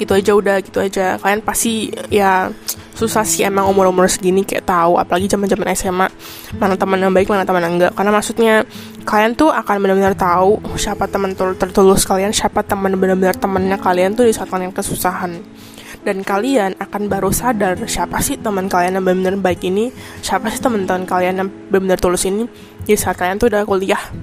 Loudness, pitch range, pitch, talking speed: -16 LUFS, 185-210 Hz, 195 Hz, 185 wpm